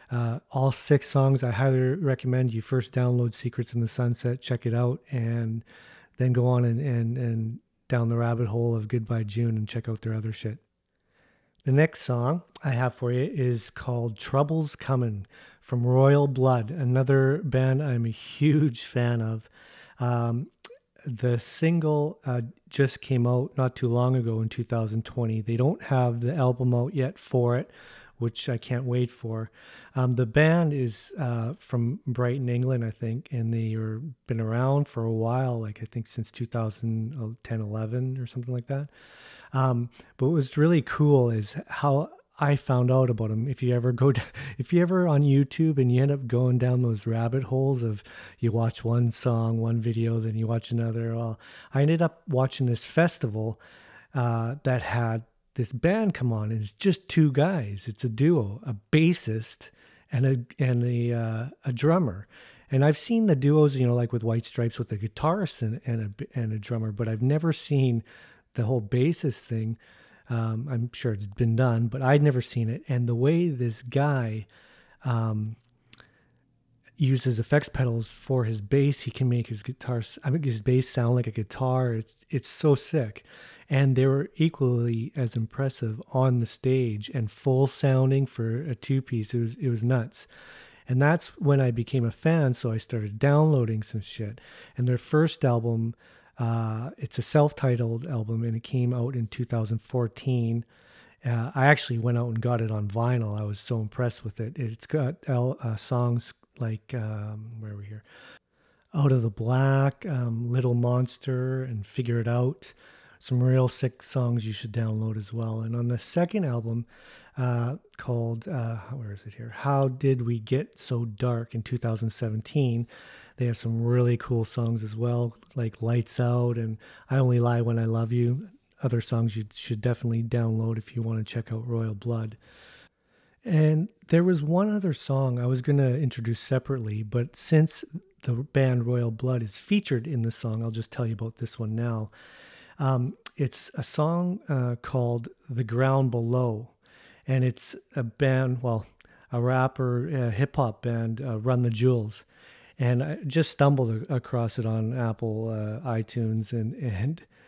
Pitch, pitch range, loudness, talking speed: 125 Hz, 115-135 Hz, -27 LUFS, 180 wpm